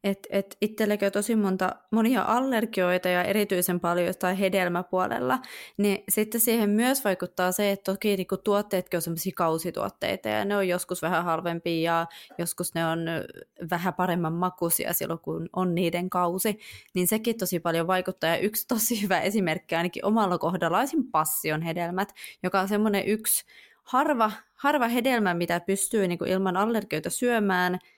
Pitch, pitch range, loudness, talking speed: 185 Hz, 175-210 Hz, -26 LUFS, 150 wpm